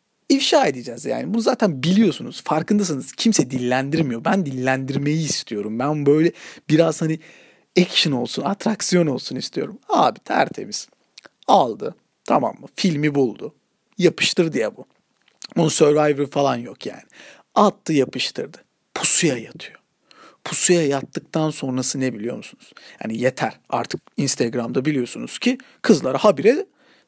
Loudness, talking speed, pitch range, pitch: -20 LUFS, 120 wpm, 135-190 Hz, 155 Hz